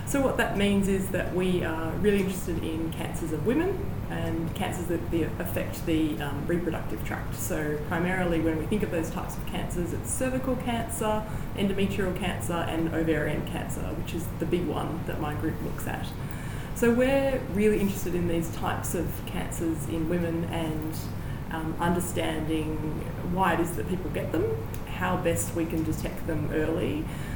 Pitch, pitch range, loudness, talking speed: 165 Hz, 155-190 Hz, -29 LUFS, 170 wpm